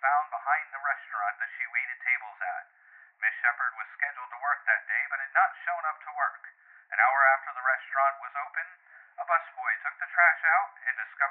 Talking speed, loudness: 205 wpm, -28 LUFS